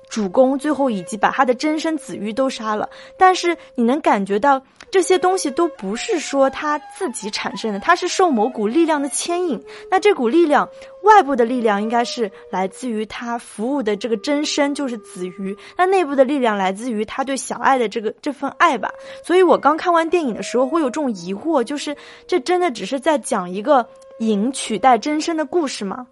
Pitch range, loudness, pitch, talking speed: 225-315 Hz, -19 LUFS, 270 Hz, 305 characters per minute